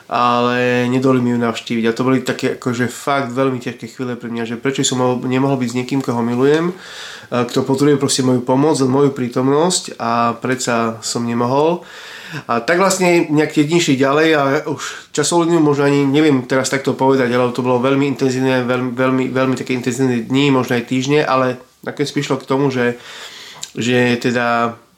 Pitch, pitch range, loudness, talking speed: 130 Hz, 125-140 Hz, -16 LUFS, 180 wpm